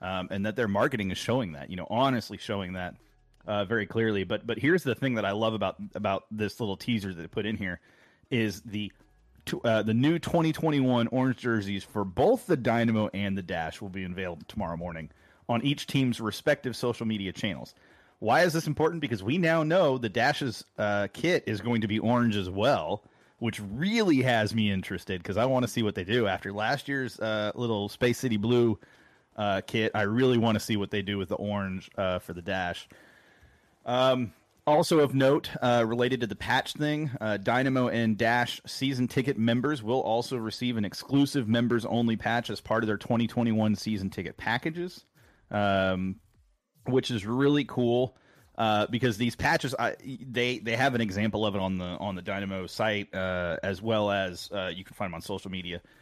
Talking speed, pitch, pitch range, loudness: 200 wpm, 110 Hz, 100-125 Hz, -28 LUFS